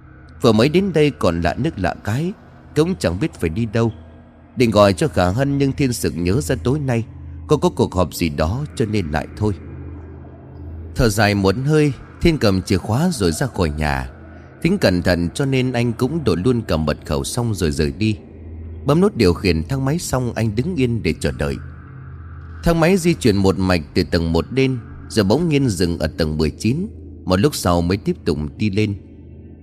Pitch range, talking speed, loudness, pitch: 80-130 Hz, 210 wpm, -19 LUFS, 95 Hz